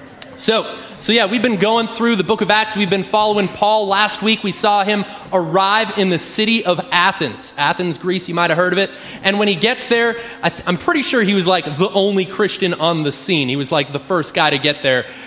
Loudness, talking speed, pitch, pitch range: -16 LUFS, 245 wpm, 200 Hz, 180-220 Hz